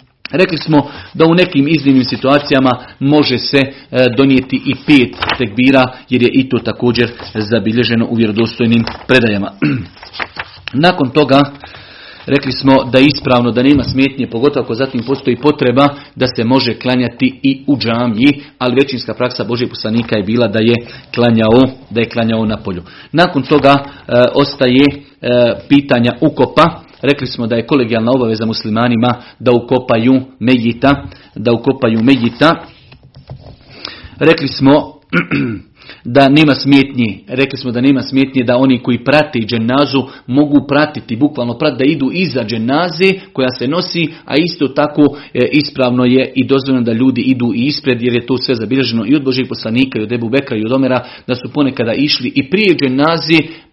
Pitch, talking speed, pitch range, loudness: 130 Hz, 155 wpm, 120-140 Hz, -12 LUFS